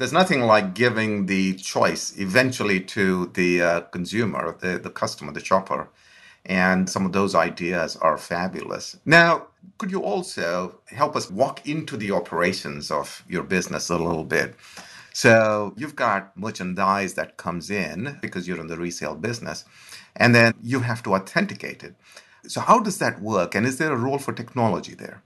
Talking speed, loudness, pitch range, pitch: 170 wpm, -22 LUFS, 95-125 Hz, 105 Hz